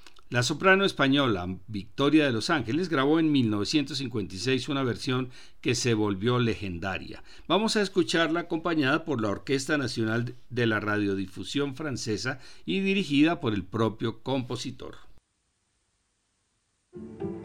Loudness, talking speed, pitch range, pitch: -27 LUFS, 115 wpm, 105-145 Hz, 120 Hz